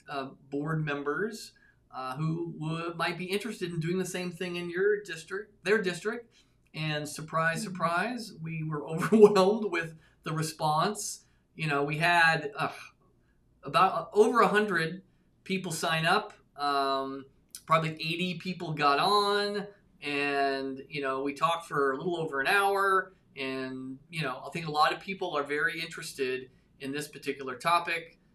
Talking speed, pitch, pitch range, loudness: 155 wpm, 165 Hz, 145-185 Hz, -29 LUFS